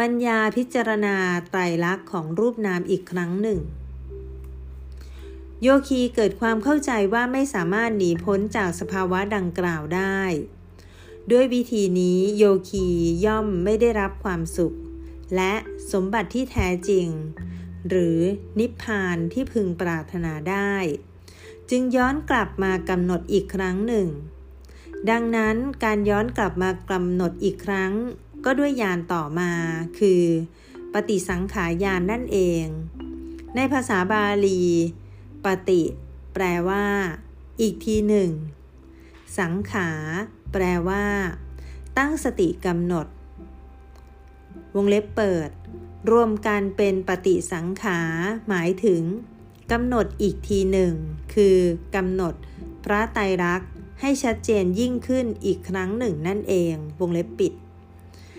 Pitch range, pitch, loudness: 165-210 Hz, 185 Hz, -23 LUFS